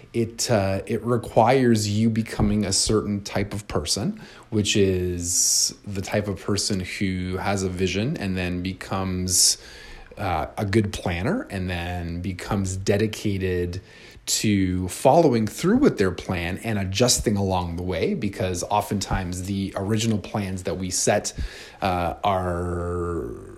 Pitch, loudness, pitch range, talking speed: 100 Hz, -23 LUFS, 95-110 Hz, 135 wpm